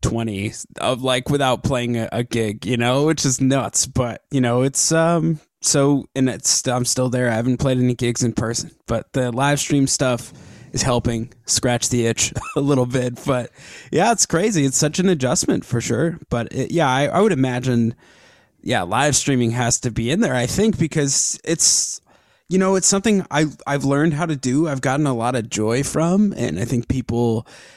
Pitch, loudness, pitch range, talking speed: 130 Hz, -19 LUFS, 120-150 Hz, 205 wpm